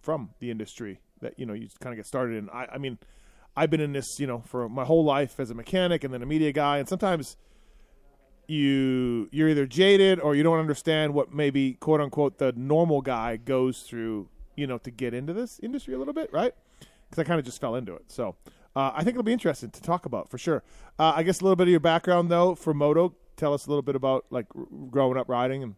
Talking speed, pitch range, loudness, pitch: 250 wpm, 130-165 Hz, -26 LUFS, 145 Hz